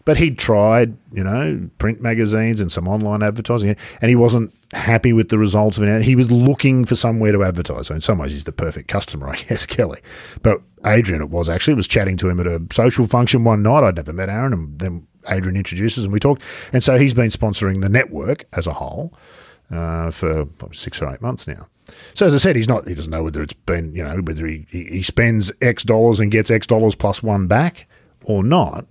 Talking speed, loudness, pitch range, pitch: 230 wpm, -17 LUFS, 90-120 Hz, 105 Hz